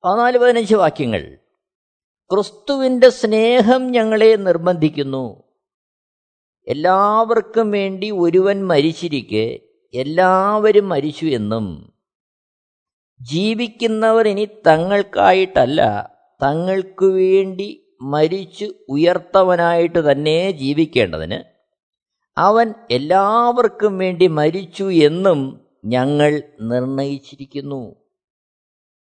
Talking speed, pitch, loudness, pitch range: 60 wpm, 185 Hz, -16 LUFS, 145-215 Hz